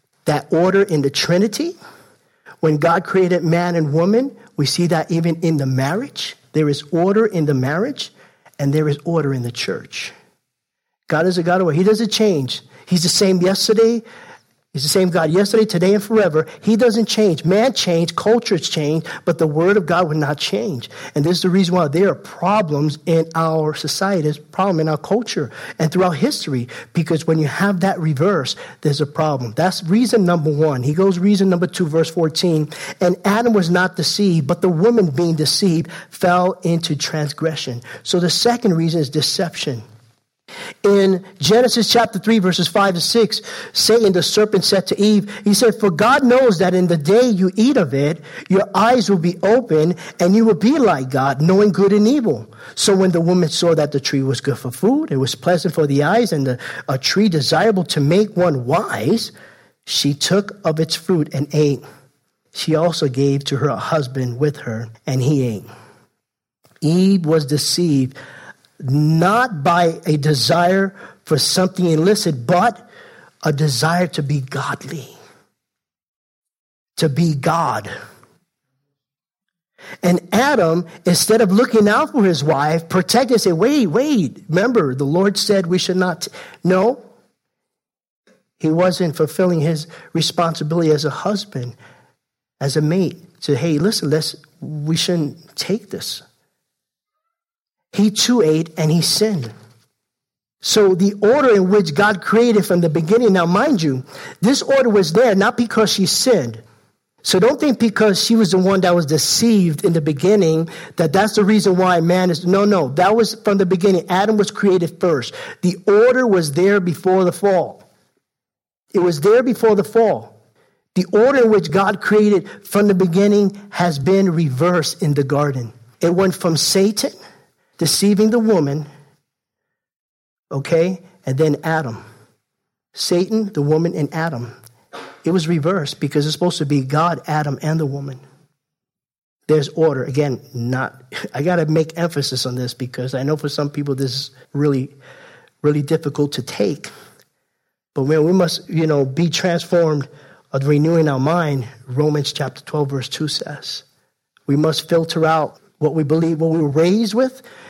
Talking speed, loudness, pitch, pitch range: 170 wpm, -17 LUFS, 170 Hz, 150-195 Hz